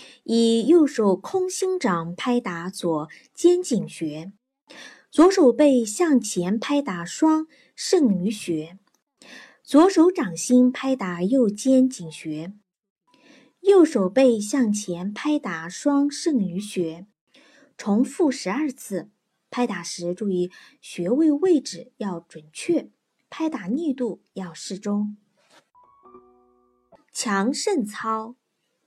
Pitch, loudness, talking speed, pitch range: 230 Hz, -22 LUFS, 150 characters per minute, 185-285 Hz